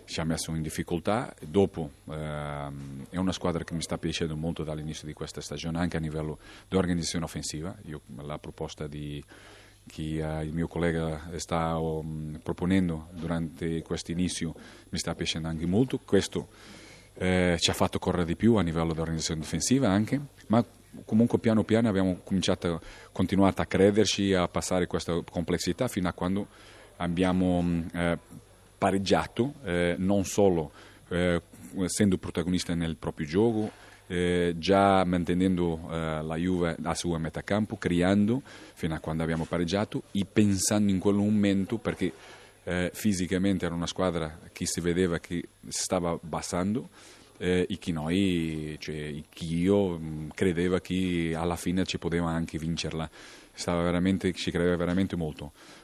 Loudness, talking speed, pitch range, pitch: -29 LUFS, 150 wpm, 80-95 Hz, 90 Hz